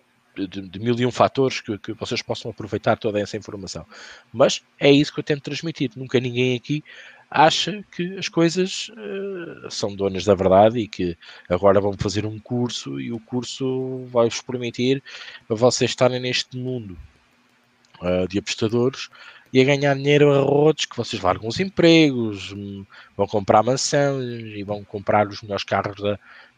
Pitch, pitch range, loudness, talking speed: 120 Hz, 105-135 Hz, -21 LUFS, 170 wpm